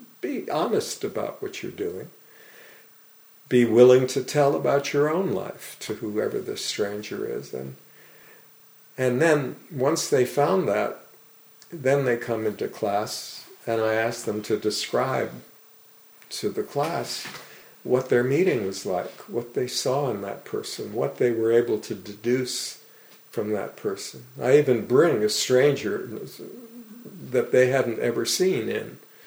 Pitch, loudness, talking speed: 140 Hz, -24 LUFS, 145 wpm